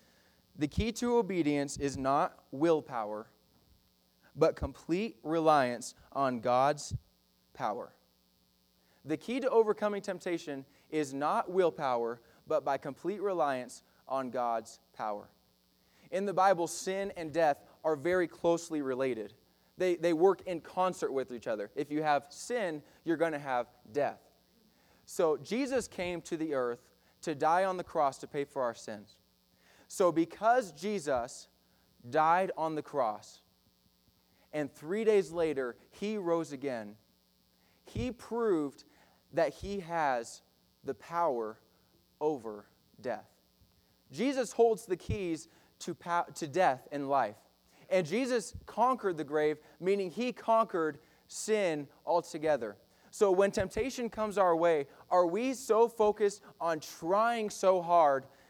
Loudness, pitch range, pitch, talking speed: -32 LUFS, 135-195 Hz, 160 Hz, 130 wpm